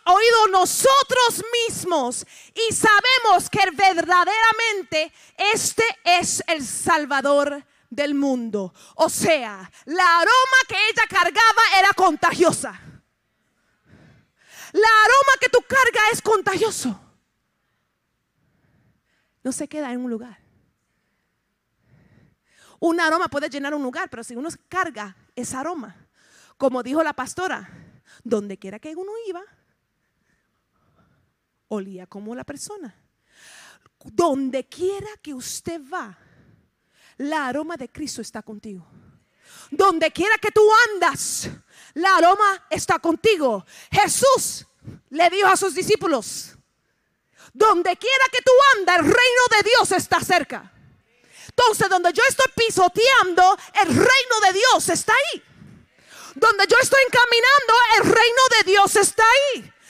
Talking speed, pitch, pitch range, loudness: 120 wpm, 365 Hz, 285-435 Hz, -18 LUFS